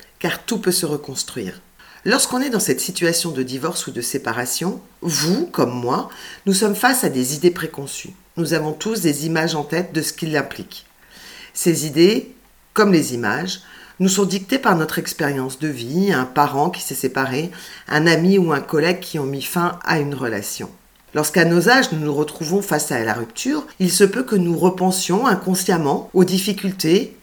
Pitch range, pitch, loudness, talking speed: 150-190 Hz, 170 Hz, -19 LUFS, 185 wpm